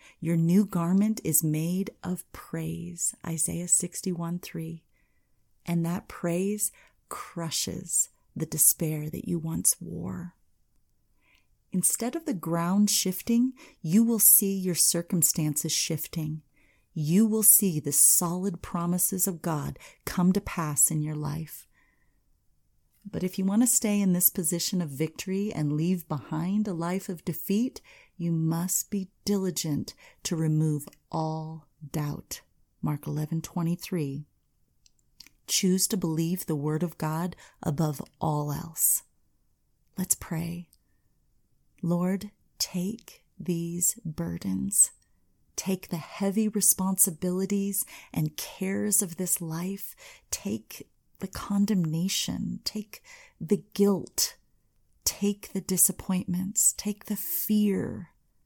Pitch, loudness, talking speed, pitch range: 175 Hz, -27 LUFS, 115 wpm, 160-200 Hz